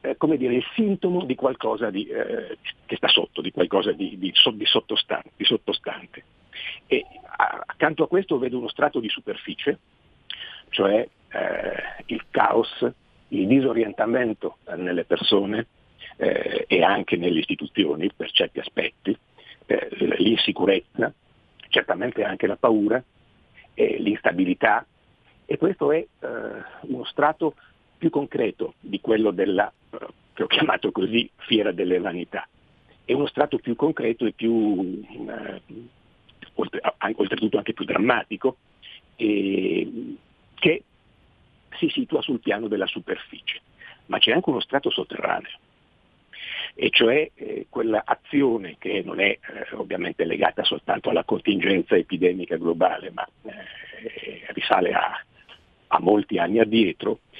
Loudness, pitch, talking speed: -23 LUFS, 285 Hz, 130 wpm